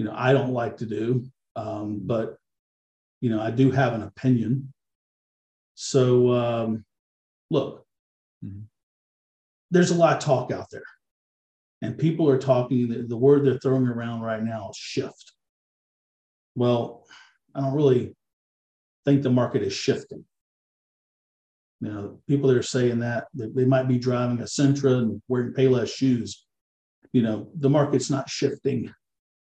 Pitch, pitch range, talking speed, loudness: 120 Hz, 105-130 Hz, 150 wpm, -24 LUFS